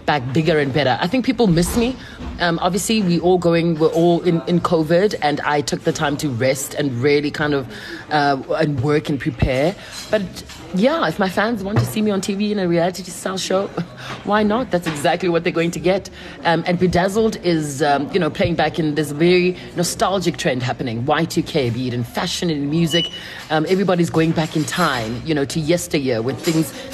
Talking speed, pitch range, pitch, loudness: 210 wpm, 150-180 Hz, 165 Hz, -19 LUFS